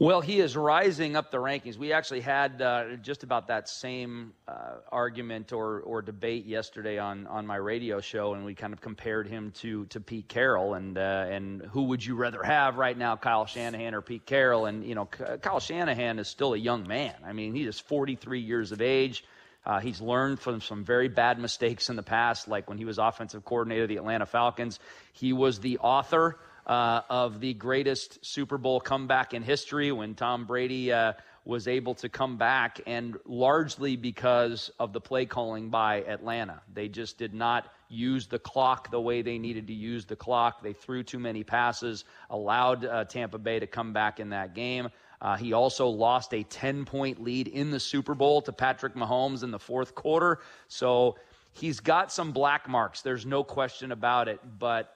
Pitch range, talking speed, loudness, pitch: 110-130 Hz, 200 wpm, -29 LUFS, 120 Hz